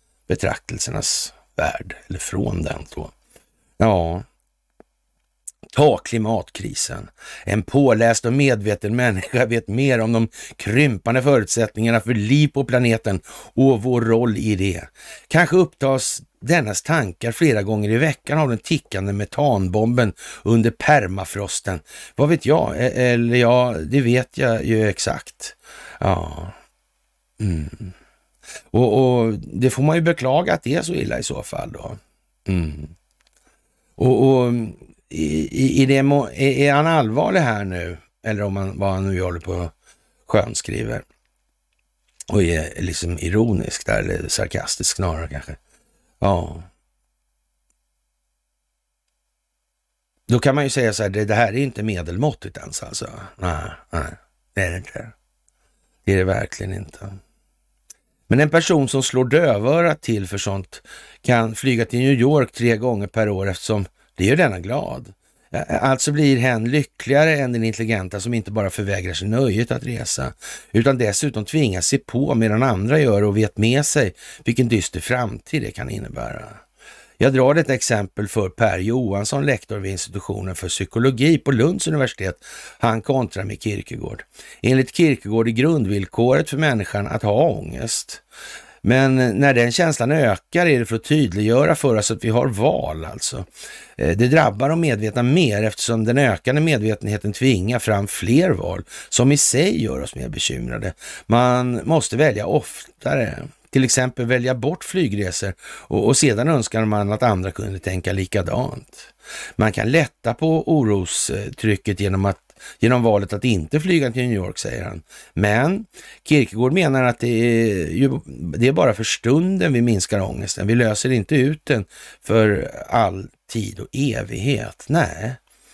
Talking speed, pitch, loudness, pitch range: 150 wpm, 115 Hz, -19 LUFS, 100-135 Hz